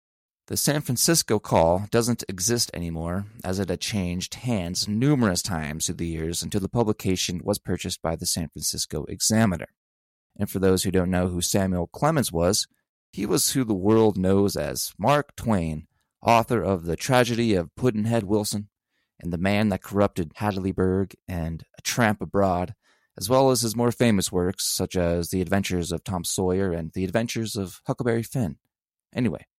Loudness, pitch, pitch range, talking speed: -24 LUFS, 95 Hz, 90-110 Hz, 170 wpm